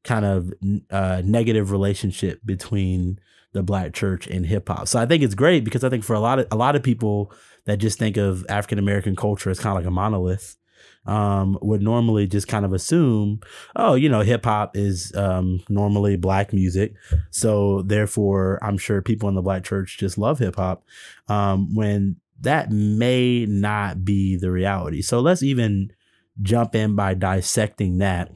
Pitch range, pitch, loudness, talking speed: 95-110 Hz, 100 Hz, -21 LUFS, 185 wpm